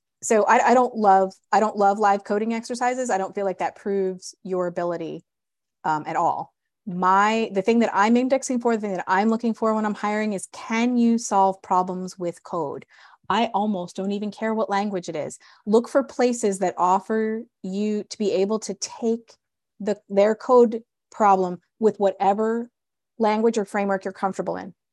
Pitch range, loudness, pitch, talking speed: 190-225 Hz, -23 LUFS, 205 Hz, 185 wpm